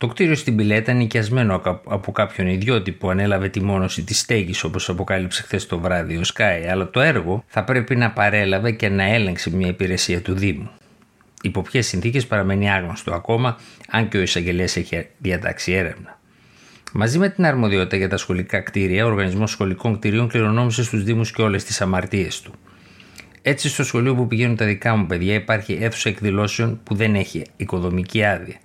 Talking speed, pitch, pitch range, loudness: 180 wpm, 100 Hz, 95-115 Hz, -20 LUFS